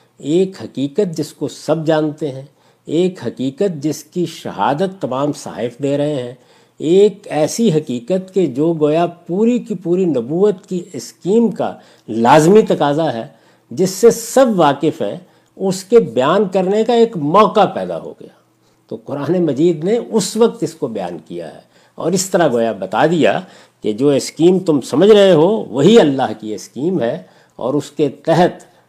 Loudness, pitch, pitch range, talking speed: -15 LUFS, 165 Hz, 145-195 Hz, 170 wpm